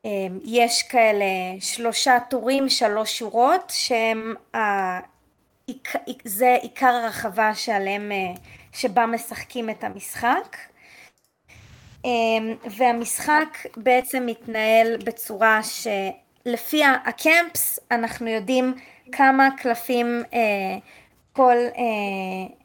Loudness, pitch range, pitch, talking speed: -22 LUFS, 220-250 Hz, 235 Hz, 70 wpm